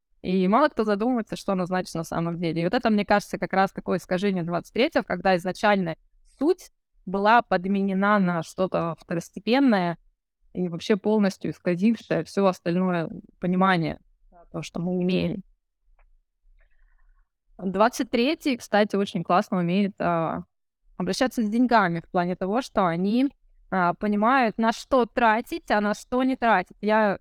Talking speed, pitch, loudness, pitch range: 140 wpm, 195 Hz, -24 LUFS, 180-225 Hz